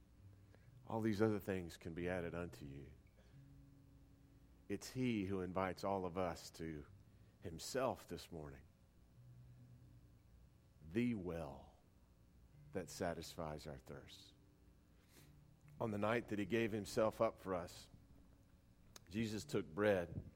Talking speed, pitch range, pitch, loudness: 115 wpm, 85-110 Hz, 95 Hz, -44 LUFS